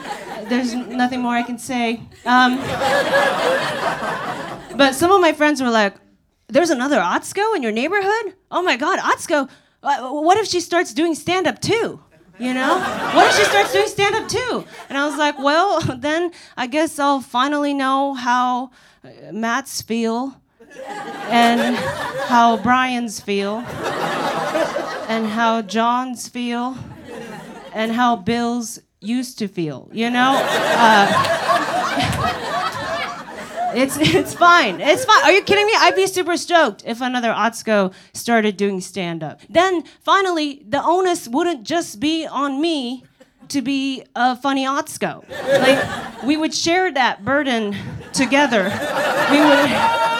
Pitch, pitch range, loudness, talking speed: 265 Hz, 235-315 Hz, -18 LUFS, 135 wpm